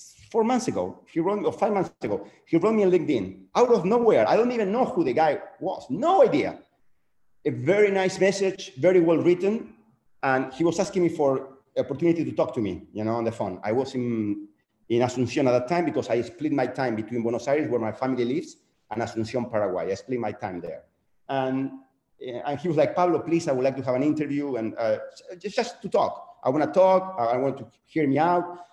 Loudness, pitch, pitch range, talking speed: -25 LUFS, 140 Hz, 120-185 Hz, 230 wpm